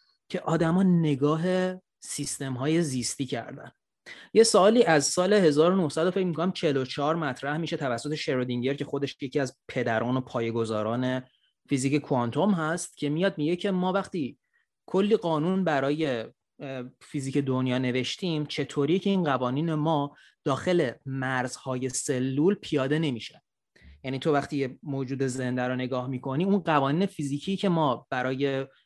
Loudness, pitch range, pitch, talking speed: -27 LUFS, 130-165 Hz, 145 Hz, 135 wpm